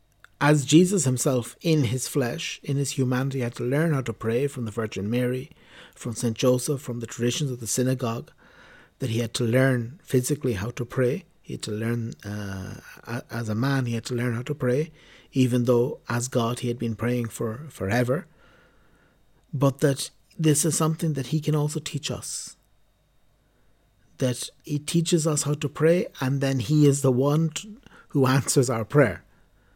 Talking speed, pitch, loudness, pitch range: 185 wpm, 130 Hz, -25 LUFS, 120-145 Hz